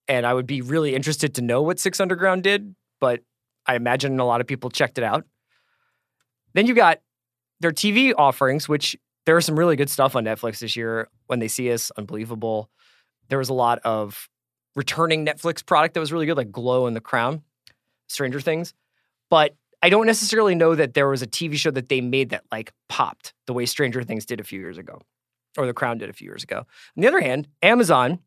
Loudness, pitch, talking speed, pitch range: -21 LUFS, 135 Hz, 215 wpm, 120-165 Hz